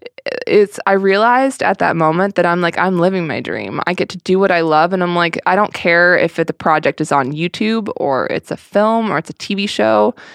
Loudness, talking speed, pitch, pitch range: -15 LUFS, 240 wpm, 180 Hz, 165-205 Hz